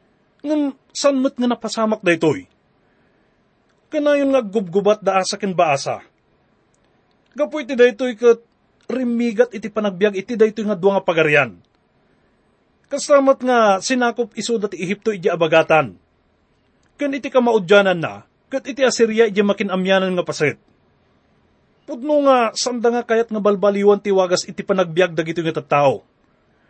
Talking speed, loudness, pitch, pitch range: 140 wpm, -18 LUFS, 215 Hz, 185-245 Hz